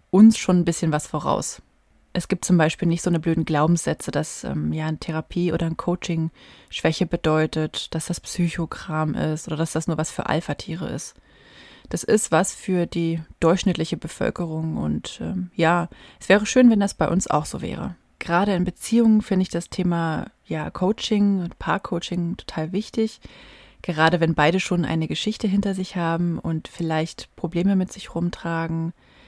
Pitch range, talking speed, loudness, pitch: 160-185 Hz, 175 wpm, -23 LUFS, 170 Hz